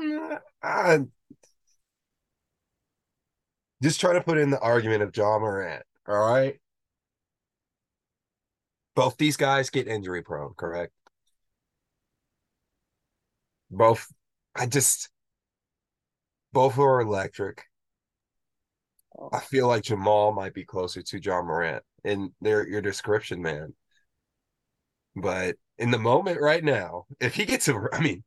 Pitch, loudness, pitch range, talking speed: 115 Hz, -25 LUFS, 105-140 Hz, 115 wpm